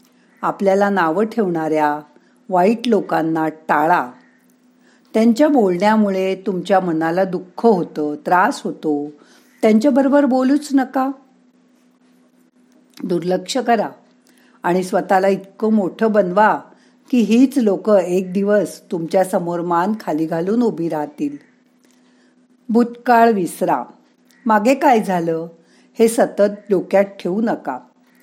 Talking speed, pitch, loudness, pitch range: 100 wpm, 210 Hz, -17 LUFS, 180-250 Hz